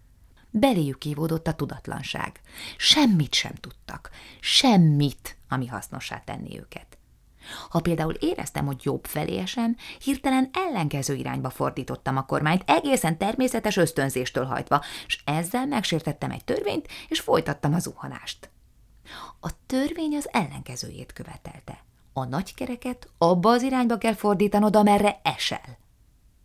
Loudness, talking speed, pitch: -25 LUFS, 120 wpm, 170 Hz